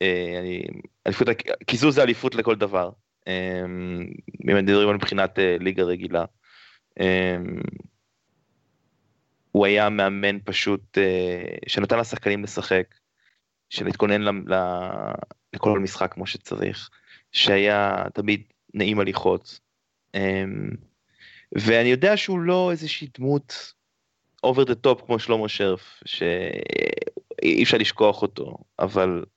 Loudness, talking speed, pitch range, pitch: -23 LUFS, 100 wpm, 95-120 Hz, 100 Hz